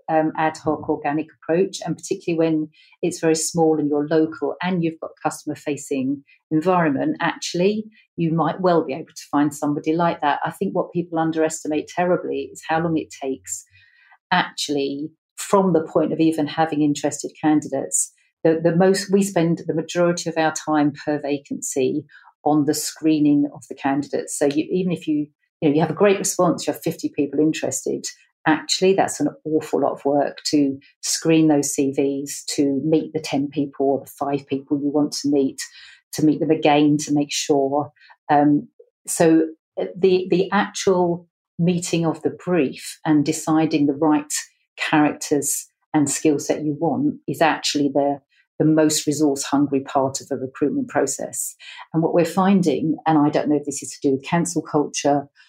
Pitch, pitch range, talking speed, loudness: 155 Hz, 145-165 Hz, 180 wpm, -21 LUFS